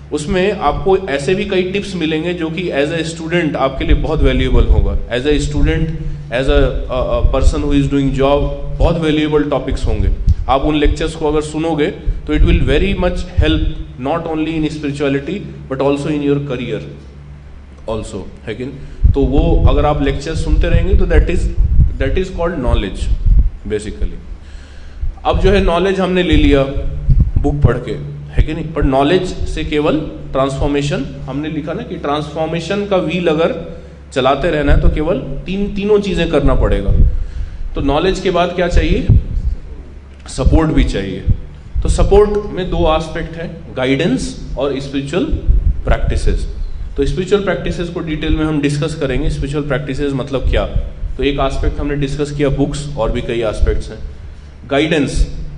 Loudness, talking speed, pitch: -16 LUFS, 160 wpm, 140 Hz